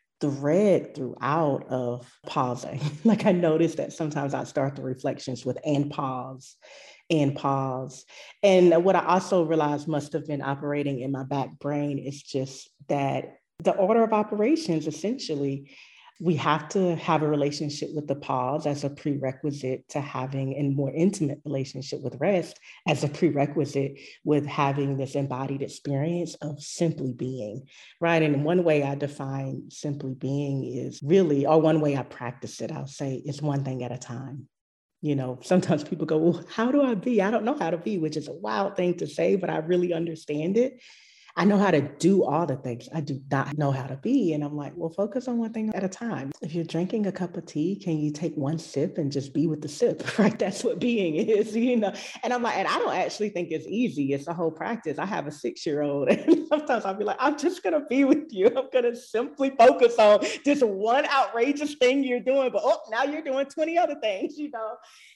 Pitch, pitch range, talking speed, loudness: 155 Hz, 140-210 Hz, 210 wpm, -26 LUFS